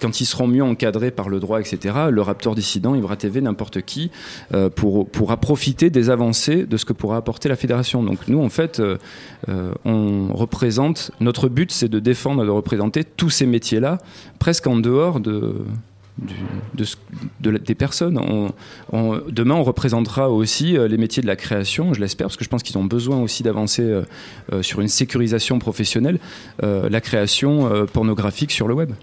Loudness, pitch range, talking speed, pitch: -20 LUFS, 105-130 Hz, 190 wpm, 115 Hz